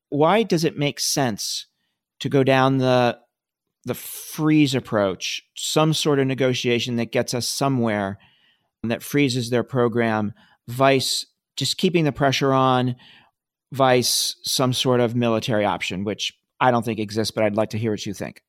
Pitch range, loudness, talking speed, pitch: 115-140 Hz, -21 LUFS, 160 wpm, 125 Hz